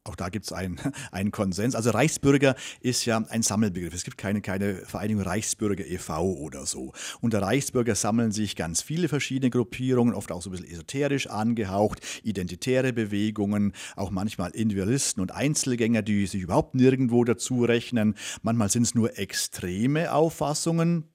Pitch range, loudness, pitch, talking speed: 100-130 Hz, -26 LUFS, 110 Hz, 160 wpm